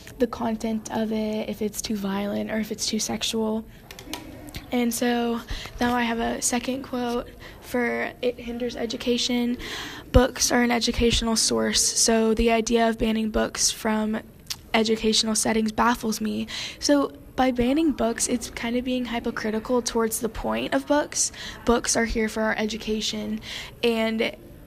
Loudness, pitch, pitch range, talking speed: -24 LUFS, 230 Hz, 220-245 Hz, 150 wpm